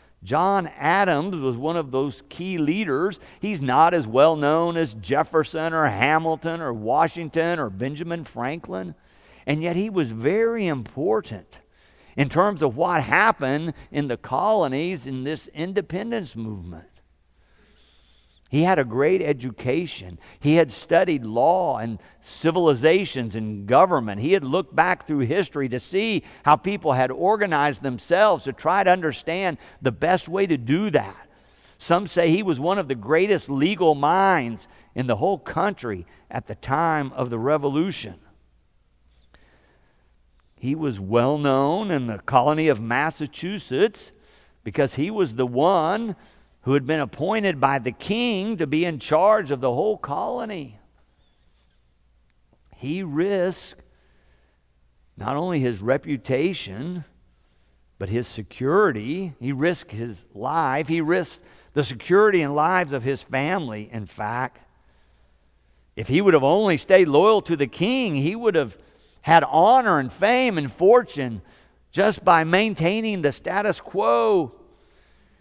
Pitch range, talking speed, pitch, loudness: 110-170 Hz, 140 wpm, 140 Hz, -22 LUFS